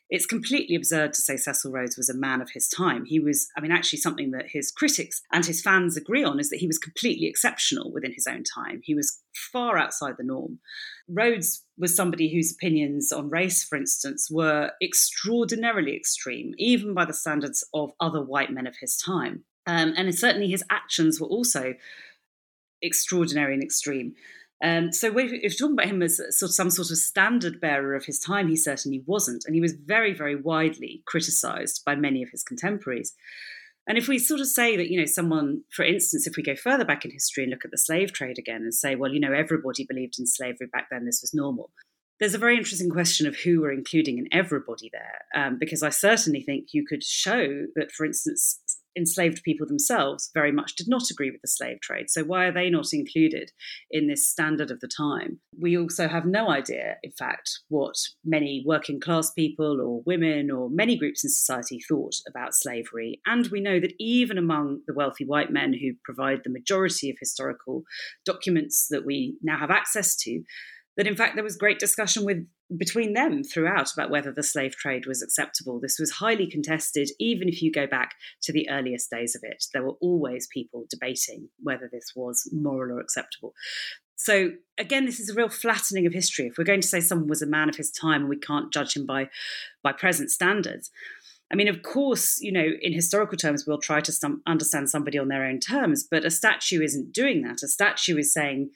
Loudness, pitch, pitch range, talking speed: -25 LUFS, 165 Hz, 145-205 Hz, 210 wpm